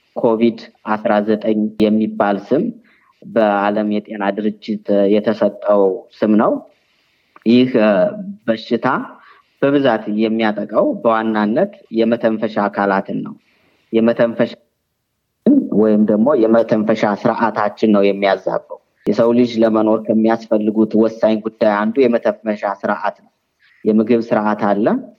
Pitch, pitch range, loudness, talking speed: 110 Hz, 105-115 Hz, -16 LUFS, 95 wpm